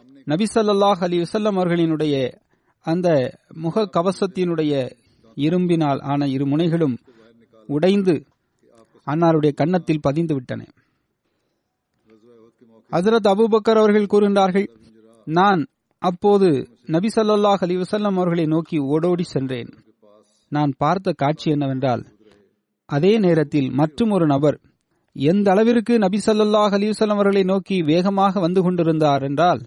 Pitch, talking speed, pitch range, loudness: 165 Hz, 100 wpm, 140-195 Hz, -19 LUFS